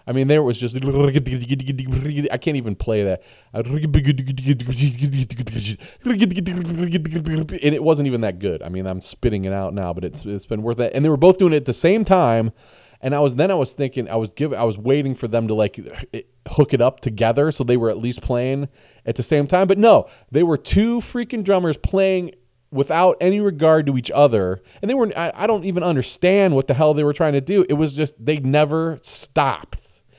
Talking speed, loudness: 215 wpm, -19 LUFS